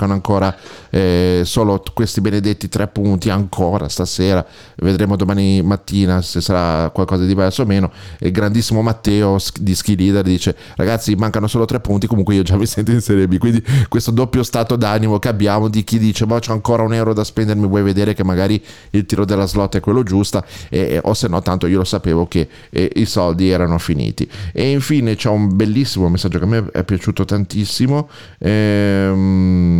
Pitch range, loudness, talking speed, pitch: 95-110 Hz, -16 LUFS, 190 wpm, 100 Hz